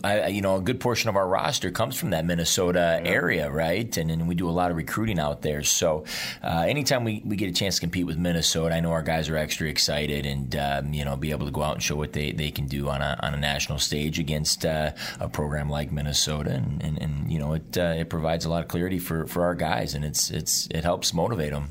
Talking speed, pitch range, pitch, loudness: 265 wpm, 75-85 Hz, 80 Hz, -25 LUFS